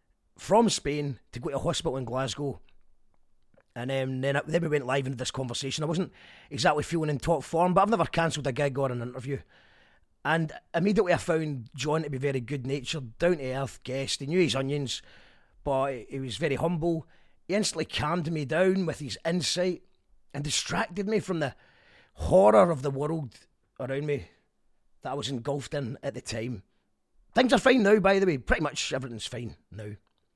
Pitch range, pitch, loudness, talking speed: 130-170 Hz, 145 Hz, -28 LUFS, 190 wpm